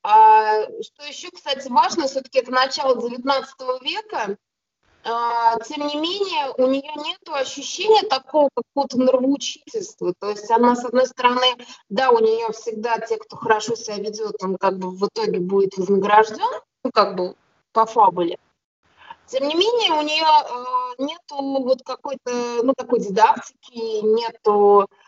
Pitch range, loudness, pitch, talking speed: 225-300 Hz, -20 LUFS, 255 Hz, 140 wpm